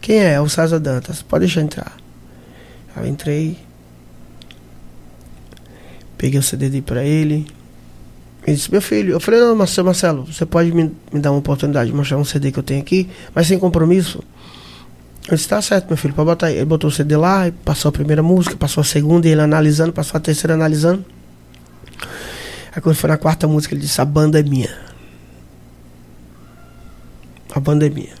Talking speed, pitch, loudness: 185 wpm, 150 Hz, -16 LUFS